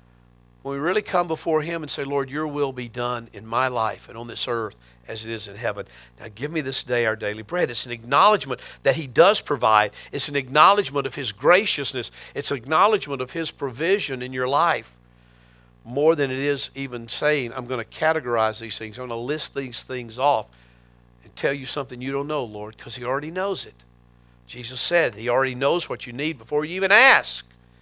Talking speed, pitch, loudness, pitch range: 215 wpm, 130 Hz, -22 LUFS, 110-145 Hz